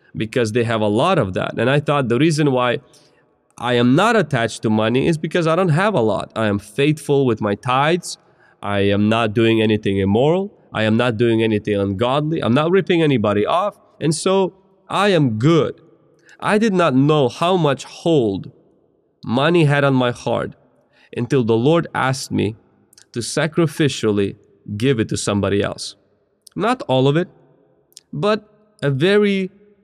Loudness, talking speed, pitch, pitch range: -18 LUFS, 170 wpm, 135 Hz, 115-165 Hz